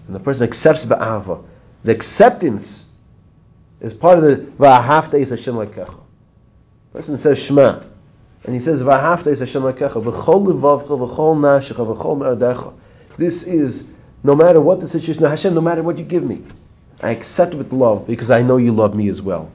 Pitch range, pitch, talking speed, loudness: 120-160 Hz, 140 Hz, 170 wpm, -15 LUFS